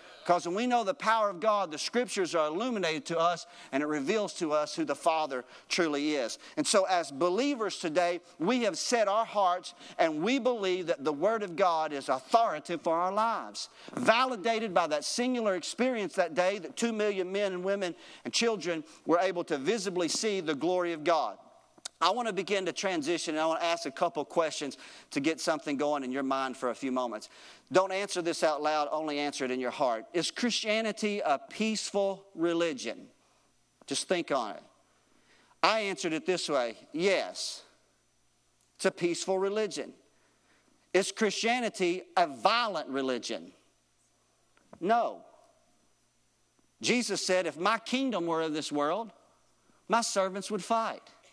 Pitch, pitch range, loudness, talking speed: 180 Hz, 160-215 Hz, -30 LUFS, 170 wpm